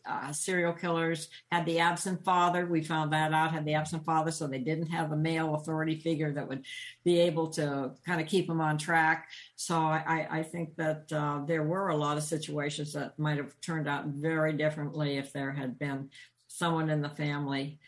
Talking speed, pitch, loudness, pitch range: 205 wpm, 155 Hz, -31 LUFS, 145-165 Hz